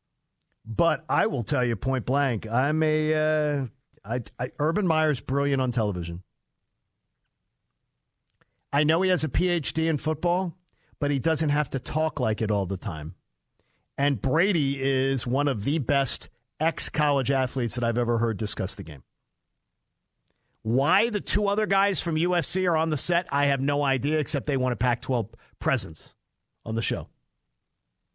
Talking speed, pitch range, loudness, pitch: 165 wpm, 120-155 Hz, -26 LUFS, 140 Hz